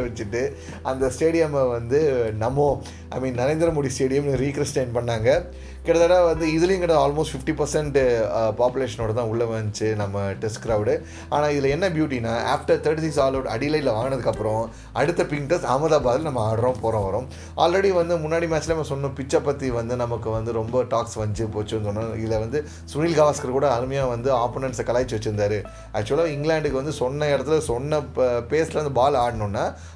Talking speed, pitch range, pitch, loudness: 160 wpm, 110-150 Hz, 130 Hz, -23 LUFS